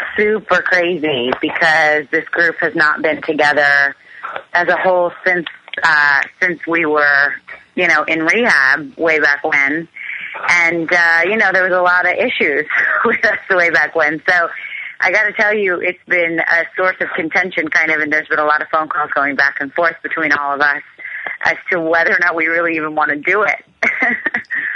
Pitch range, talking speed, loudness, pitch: 150-180 Hz, 190 wpm, -14 LUFS, 165 Hz